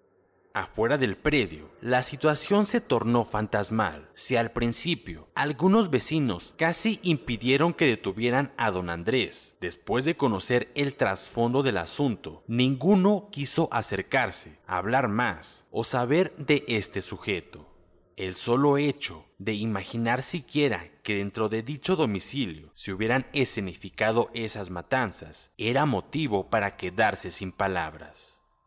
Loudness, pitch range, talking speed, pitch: -26 LUFS, 100-145 Hz, 125 wpm, 120 Hz